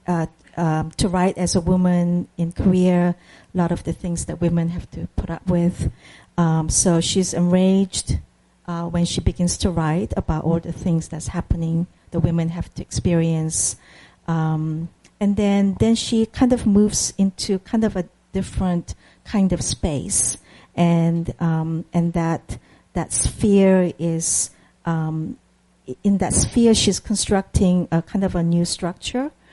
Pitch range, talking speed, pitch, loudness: 165-190 Hz, 155 wpm, 175 Hz, -21 LUFS